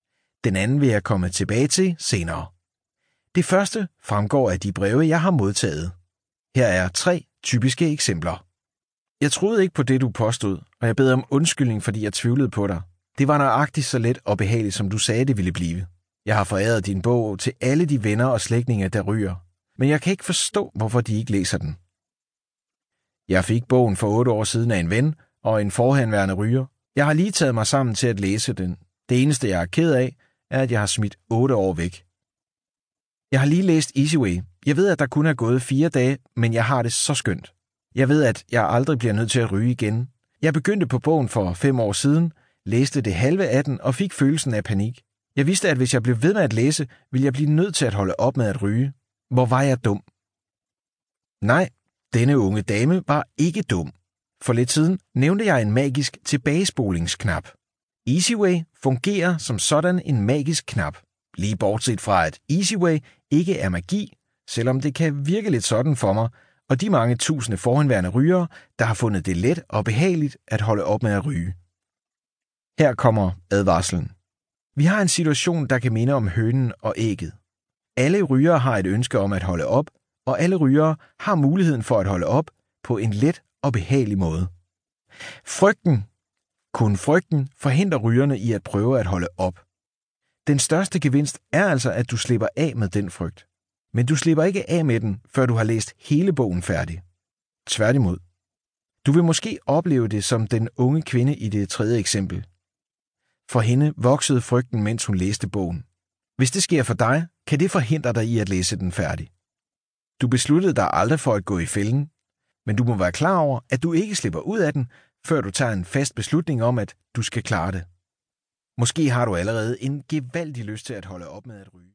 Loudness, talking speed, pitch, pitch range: -21 LUFS, 200 wpm, 120 Hz, 100-145 Hz